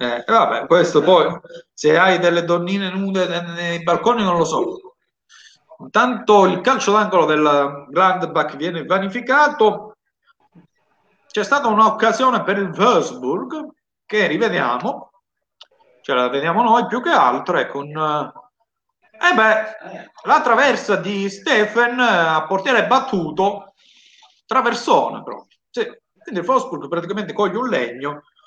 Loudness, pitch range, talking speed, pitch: -17 LUFS, 175-255 Hz, 120 wpm, 210 Hz